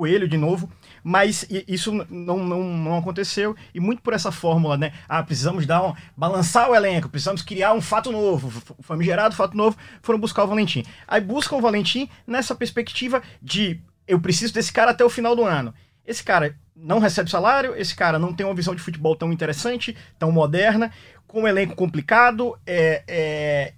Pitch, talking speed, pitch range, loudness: 190 Hz, 185 wpm, 165-220 Hz, -21 LUFS